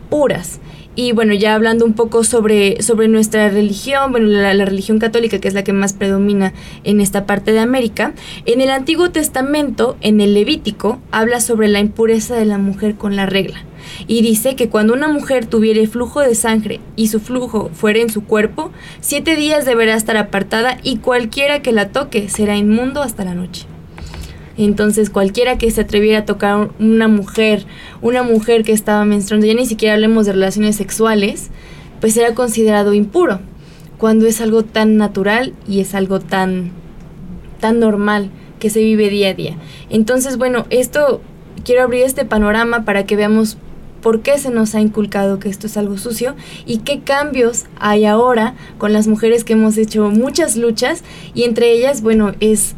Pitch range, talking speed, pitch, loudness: 205-235 Hz, 180 wpm, 220 Hz, -14 LUFS